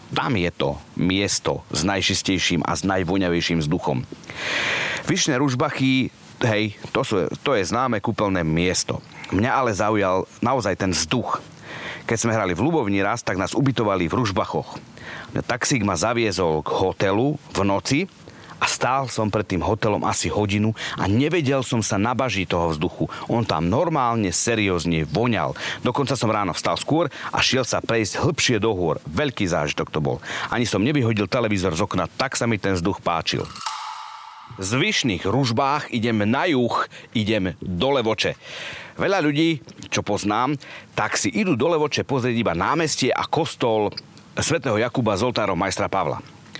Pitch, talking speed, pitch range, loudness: 105 Hz, 155 wpm, 95-125 Hz, -22 LUFS